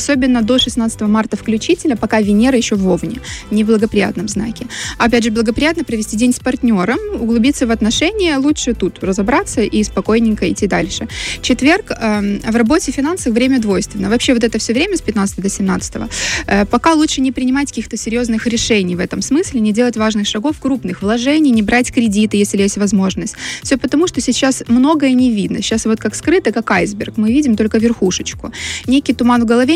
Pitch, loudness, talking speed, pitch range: 235 Hz, -14 LUFS, 180 wpm, 215-265 Hz